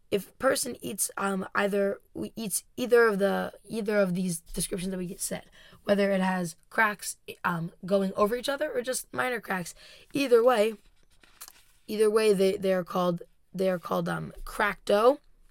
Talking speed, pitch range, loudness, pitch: 175 wpm, 190-225 Hz, -28 LUFS, 200 Hz